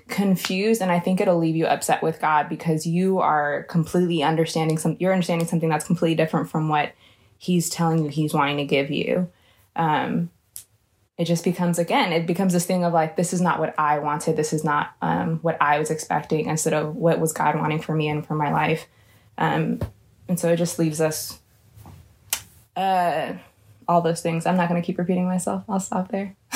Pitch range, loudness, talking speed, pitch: 150-175 Hz, -23 LUFS, 205 wpm, 160 Hz